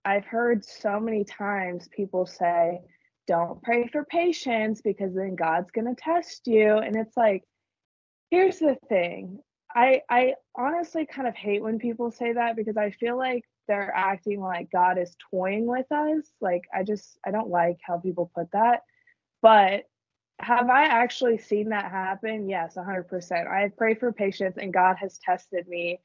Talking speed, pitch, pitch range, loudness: 170 wpm, 210 Hz, 185-240 Hz, -25 LUFS